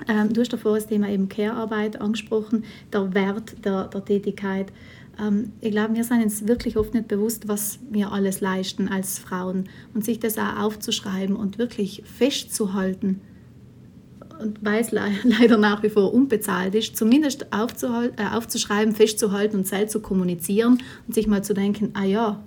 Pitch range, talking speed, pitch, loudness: 200-225 Hz, 155 wpm, 210 Hz, -23 LUFS